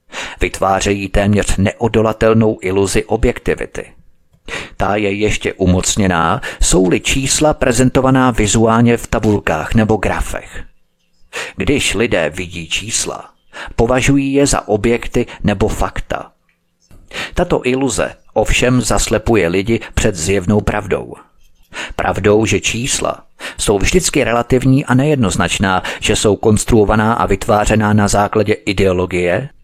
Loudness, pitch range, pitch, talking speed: -14 LUFS, 100-120 Hz, 105 Hz, 105 wpm